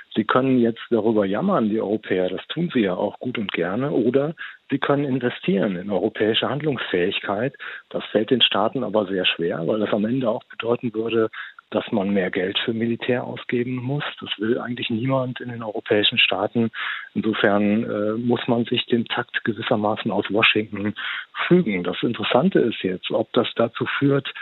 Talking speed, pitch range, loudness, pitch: 175 wpm, 110-130 Hz, -22 LUFS, 120 Hz